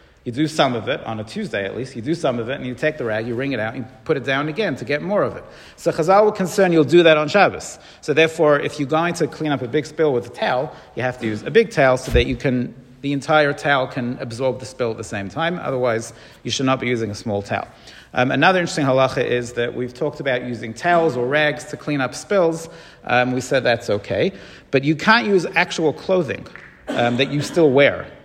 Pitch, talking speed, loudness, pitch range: 140 Hz, 260 wpm, -19 LUFS, 125-155 Hz